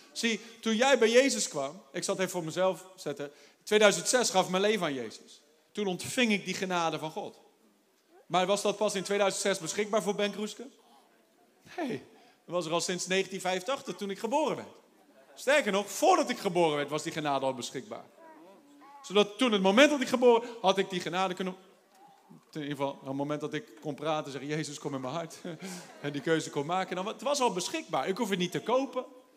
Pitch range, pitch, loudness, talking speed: 160-230 Hz, 190 Hz, -30 LUFS, 210 wpm